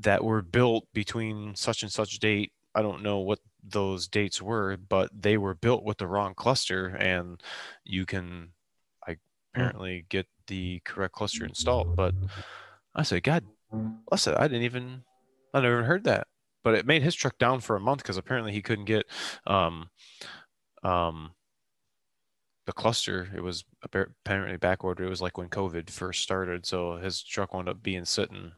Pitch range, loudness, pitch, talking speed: 90-110 Hz, -29 LUFS, 100 Hz, 180 wpm